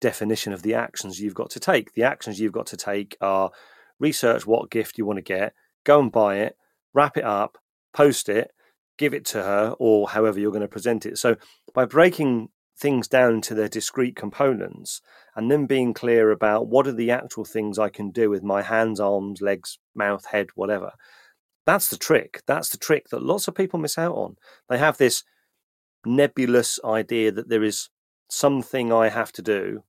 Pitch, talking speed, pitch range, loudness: 110 Hz, 195 wpm, 105-130 Hz, -23 LUFS